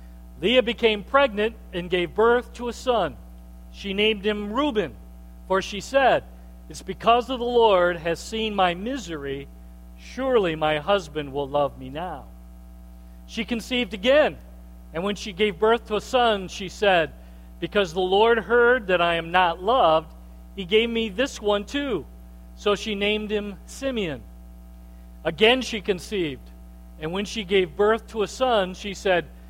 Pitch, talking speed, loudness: 190 Hz, 160 wpm, -23 LUFS